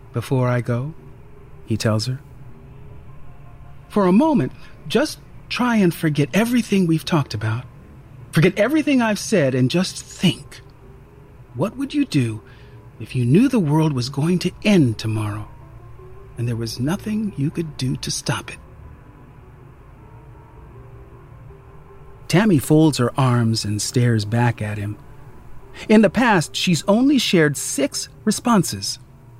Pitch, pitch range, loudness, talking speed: 135 Hz, 125-180 Hz, -19 LUFS, 135 wpm